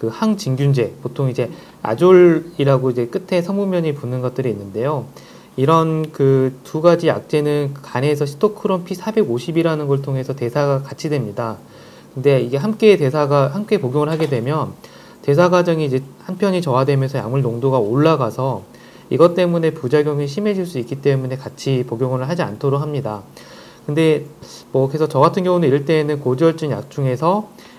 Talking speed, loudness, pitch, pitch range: 350 characters per minute, -18 LUFS, 145 Hz, 130-165 Hz